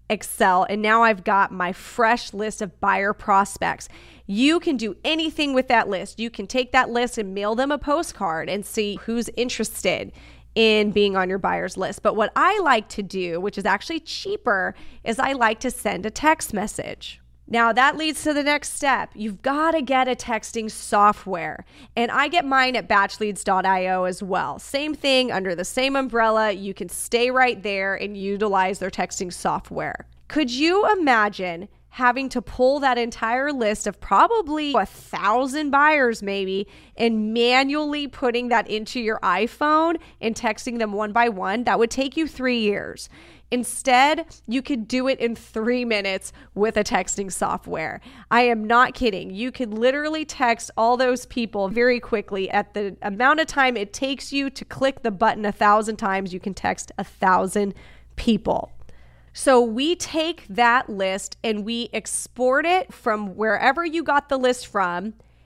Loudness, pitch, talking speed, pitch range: -22 LUFS, 230 Hz, 175 wpm, 205-260 Hz